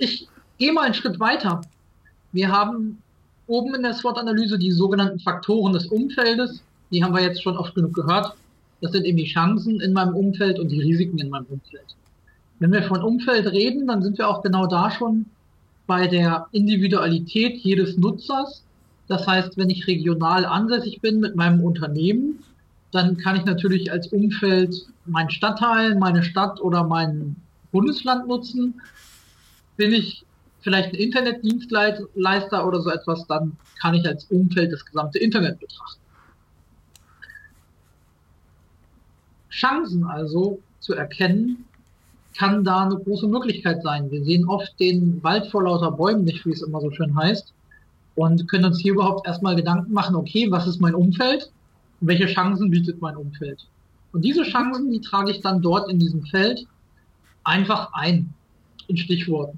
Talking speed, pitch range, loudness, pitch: 155 wpm, 165-210 Hz, -21 LUFS, 185 Hz